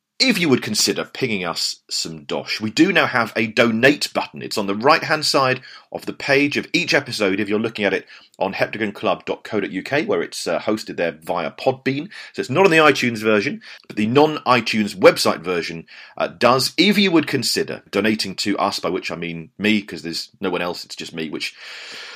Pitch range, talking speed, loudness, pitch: 105-155 Hz, 210 wpm, -19 LUFS, 125 Hz